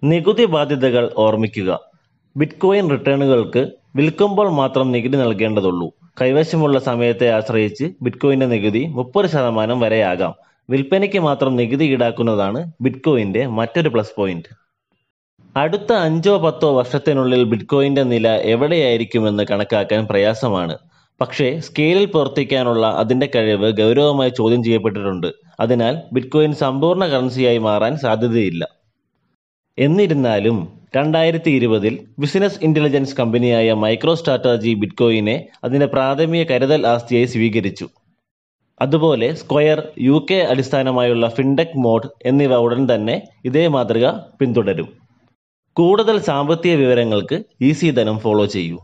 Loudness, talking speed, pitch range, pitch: -17 LUFS, 100 wpm, 115-150 Hz, 130 Hz